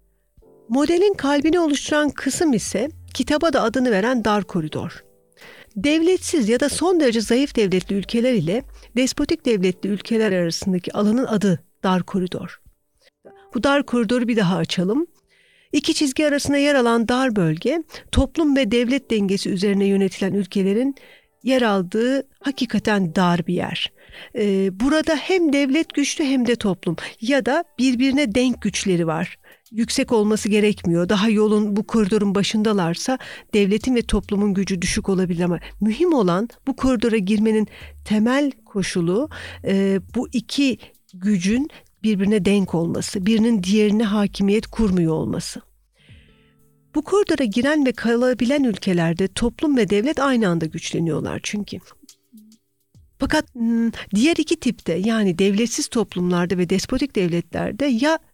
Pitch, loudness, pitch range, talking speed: 225 Hz, -20 LUFS, 195-275 Hz, 130 wpm